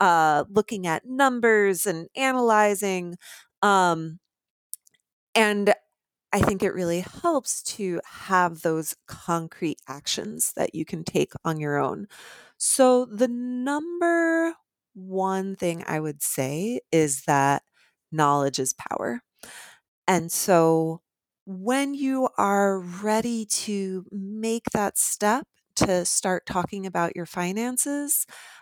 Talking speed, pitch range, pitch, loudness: 115 wpm, 170-235 Hz, 195 Hz, -24 LUFS